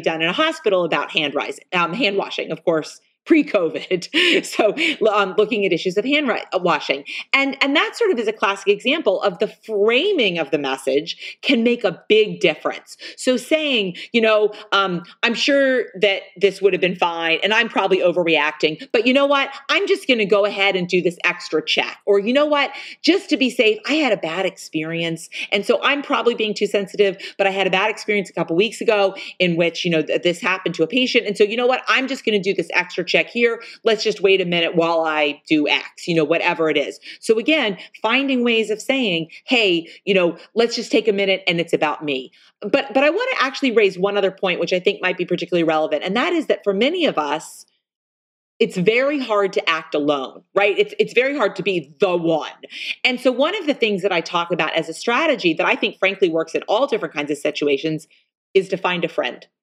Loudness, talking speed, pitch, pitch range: -19 LUFS, 230 wpm, 200 Hz, 175-255 Hz